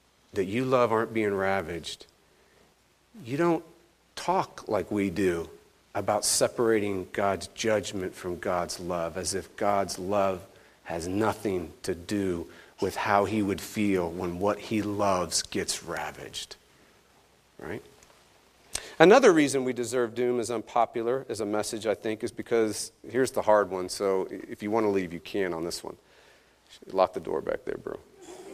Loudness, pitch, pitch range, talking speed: -28 LUFS, 105 Hz, 95-120 Hz, 155 wpm